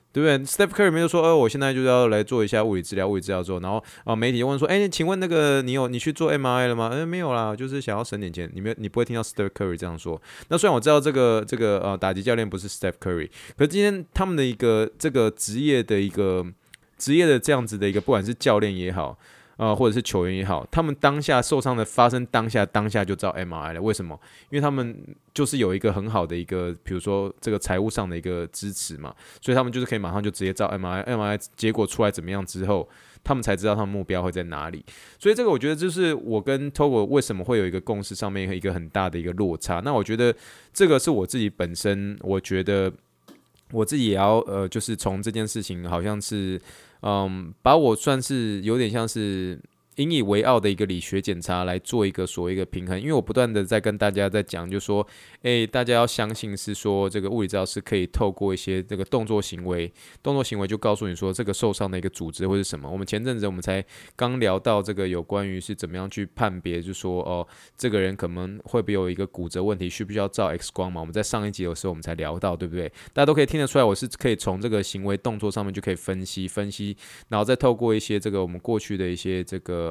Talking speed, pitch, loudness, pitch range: 395 characters per minute, 105 Hz, -24 LUFS, 95-120 Hz